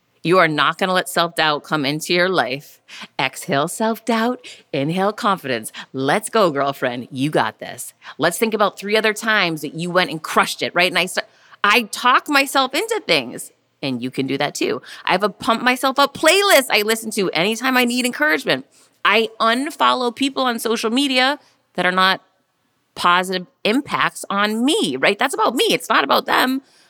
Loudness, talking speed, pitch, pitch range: -18 LUFS, 185 wpm, 205 Hz, 165-250 Hz